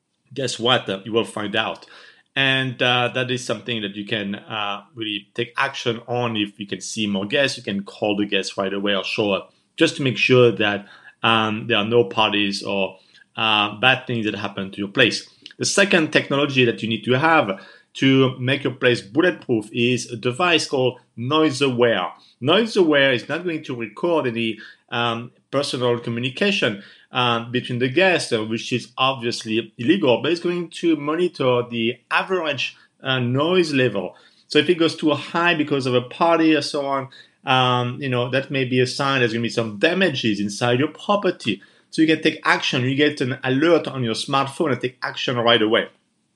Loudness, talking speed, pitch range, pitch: -20 LUFS, 190 wpm, 110-140 Hz, 125 Hz